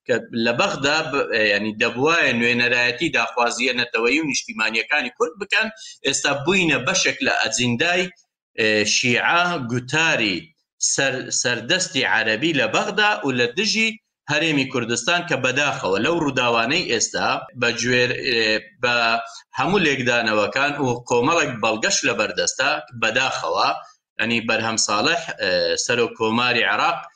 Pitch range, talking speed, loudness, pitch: 120-180 Hz, 105 wpm, -19 LUFS, 130 Hz